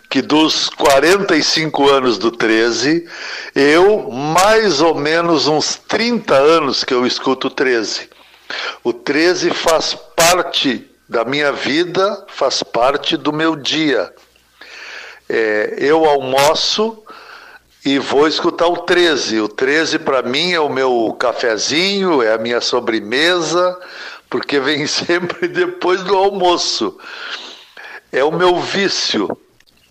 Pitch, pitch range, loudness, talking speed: 175 Hz, 150-220 Hz, -15 LUFS, 120 wpm